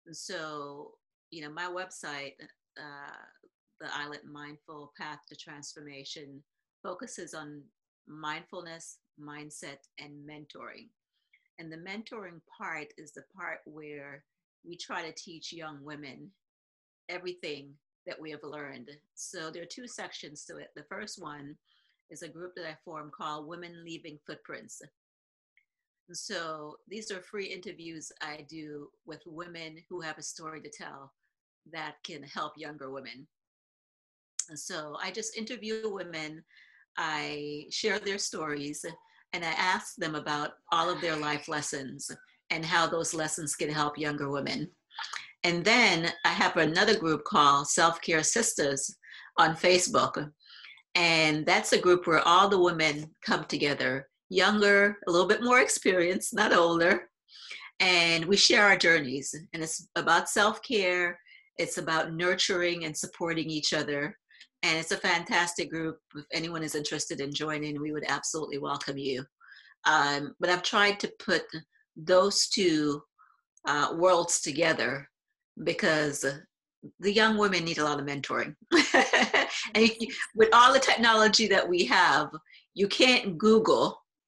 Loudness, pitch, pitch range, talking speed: -27 LUFS, 160 Hz, 150-185 Hz, 140 wpm